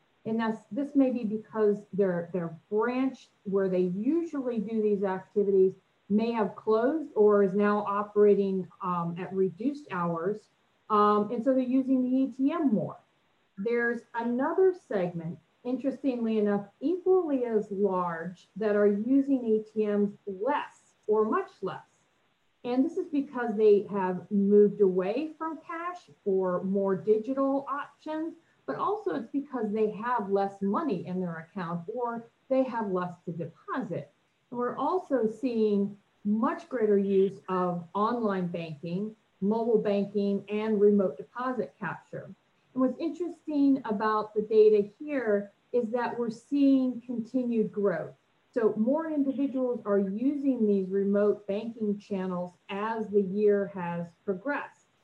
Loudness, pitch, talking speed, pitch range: -29 LUFS, 215 Hz, 135 wpm, 200-255 Hz